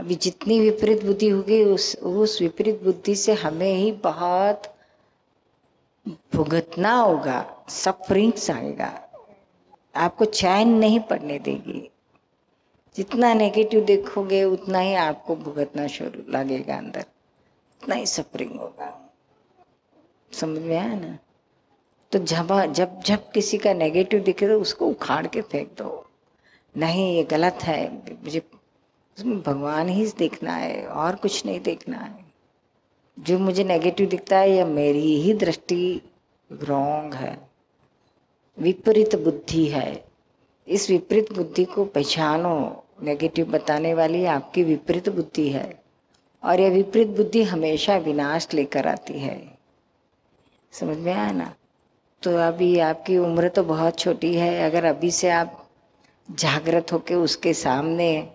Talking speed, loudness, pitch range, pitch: 125 wpm, -22 LUFS, 160-200 Hz, 175 Hz